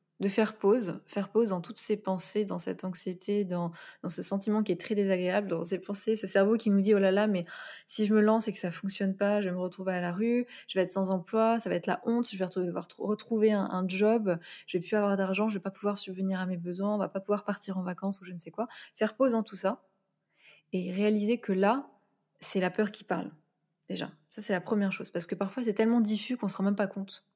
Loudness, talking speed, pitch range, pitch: -30 LUFS, 280 wpm, 185-215 Hz, 200 Hz